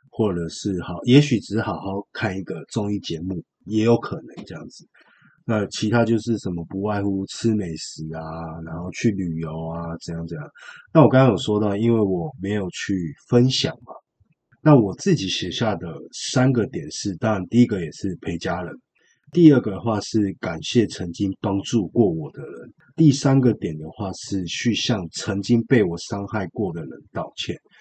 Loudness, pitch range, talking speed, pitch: -22 LUFS, 95-120 Hz, 260 characters per minute, 105 Hz